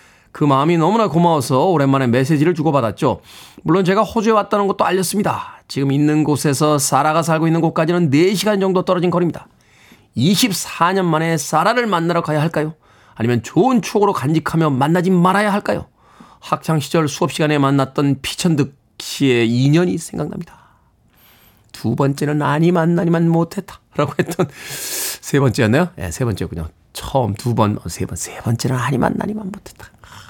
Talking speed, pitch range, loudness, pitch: 360 characters per minute, 135-180 Hz, -17 LUFS, 155 Hz